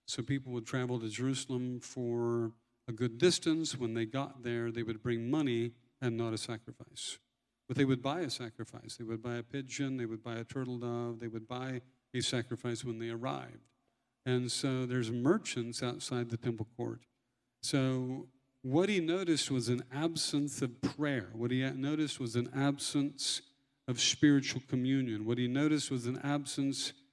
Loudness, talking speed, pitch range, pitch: -35 LUFS, 175 wpm, 120-135 Hz, 125 Hz